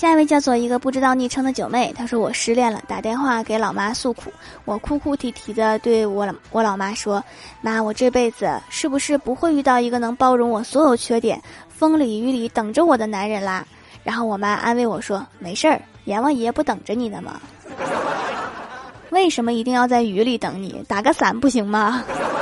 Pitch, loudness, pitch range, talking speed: 240 Hz, -20 LUFS, 220-265 Hz, 295 characters per minute